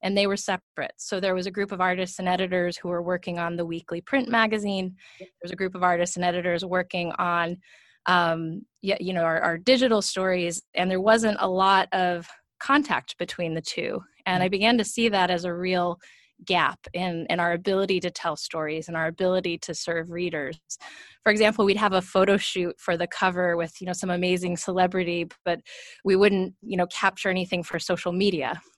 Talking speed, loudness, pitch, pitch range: 200 wpm, -25 LUFS, 180 Hz, 175-195 Hz